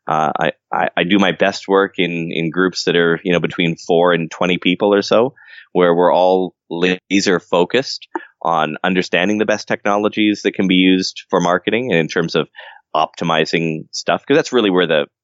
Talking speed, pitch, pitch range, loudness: 195 wpm, 90 Hz, 85-100 Hz, -16 LUFS